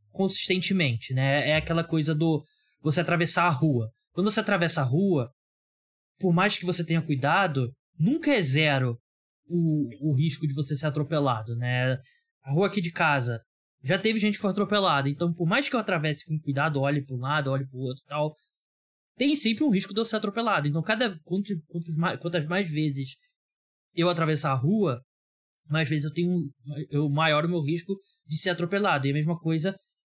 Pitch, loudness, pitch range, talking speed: 160 Hz, -26 LUFS, 145-190 Hz, 190 wpm